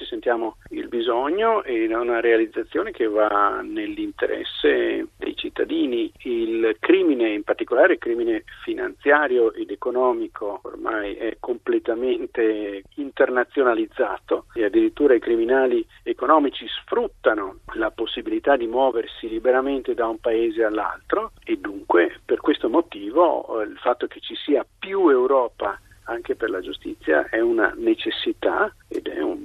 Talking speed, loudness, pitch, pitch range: 115 wpm, -22 LUFS, 345 Hz, 315-375 Hz